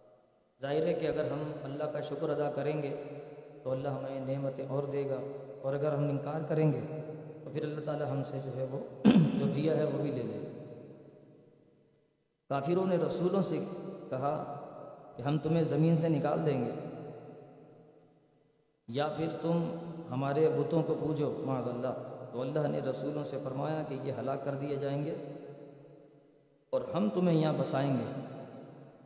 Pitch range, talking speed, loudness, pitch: 140-155 Hz, 170 wpm, -33 LUFS, 150 Hz